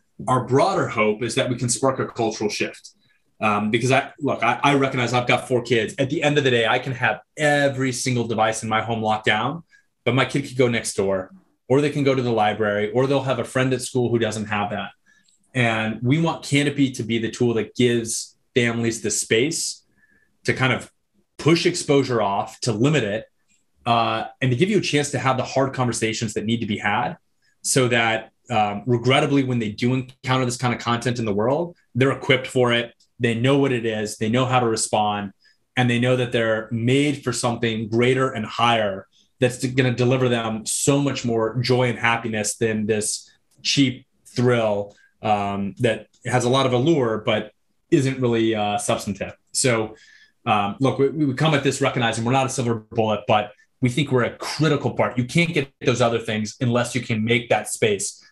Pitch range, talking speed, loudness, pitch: 110-130 Hz, 210 wpm, -21 LUFS, 120 Hz